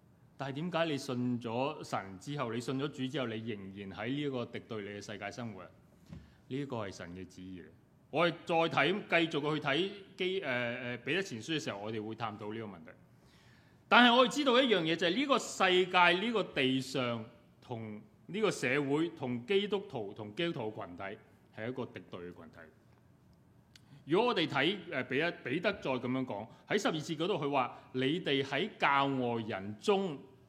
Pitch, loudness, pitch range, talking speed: 130 Hz, -33 LUFS, 115-165 Hz, 275 characters per minute